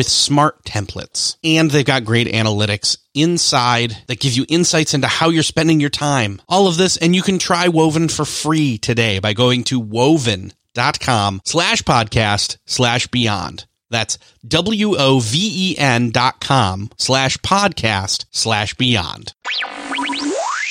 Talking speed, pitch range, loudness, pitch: 130 wpm, 115-160 Hz, -16 LUFS, 130 Hz